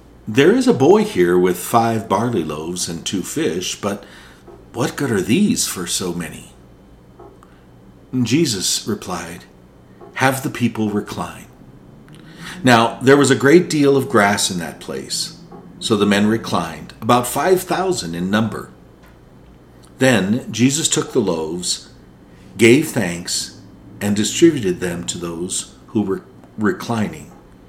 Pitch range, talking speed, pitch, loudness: 85-130 Hz, 135 wpm, 105 Hz, -17 LUFS